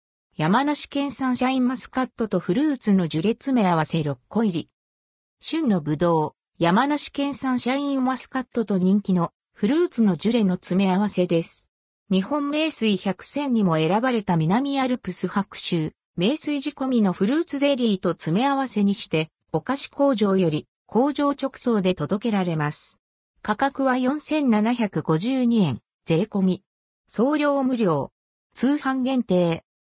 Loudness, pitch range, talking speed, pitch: -23 LUFS, 175-265 Hz, 285 characters per minute, 215 Hz